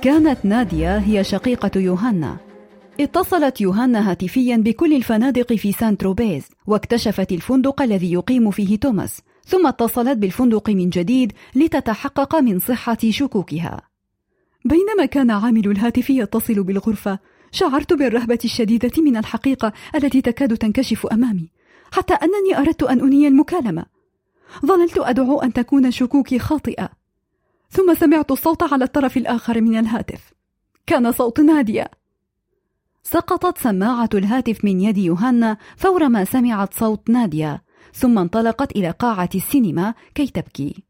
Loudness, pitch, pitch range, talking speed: -18 LUFS, 240 Hz, 210-275 Hz, 125 wpm